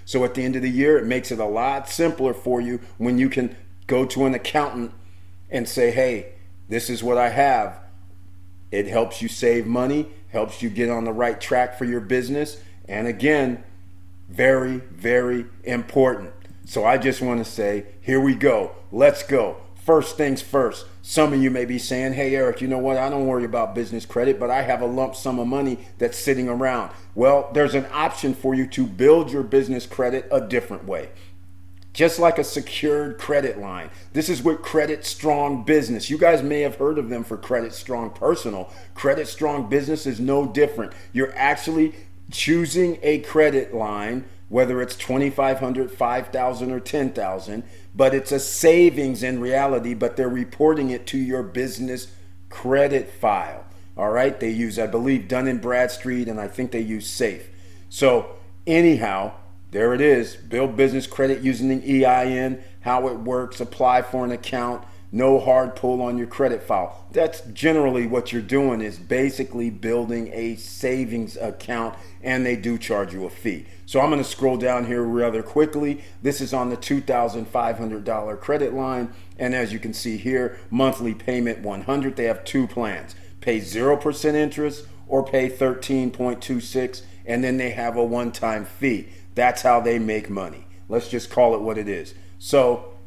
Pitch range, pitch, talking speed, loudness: 110-135 Hz, 125 Hz, 175 wpm, -22 LUFS